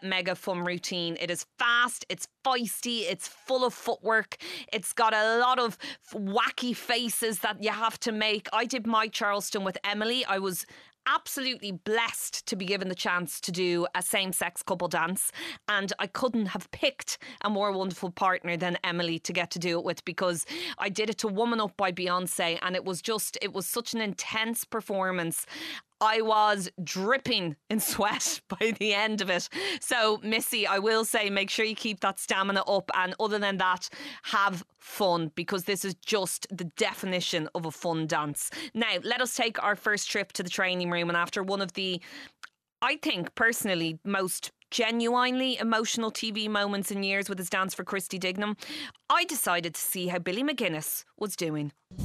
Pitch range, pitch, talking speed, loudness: 185-225 Hz, 200 Hz, 185 wpm, -29 LUFS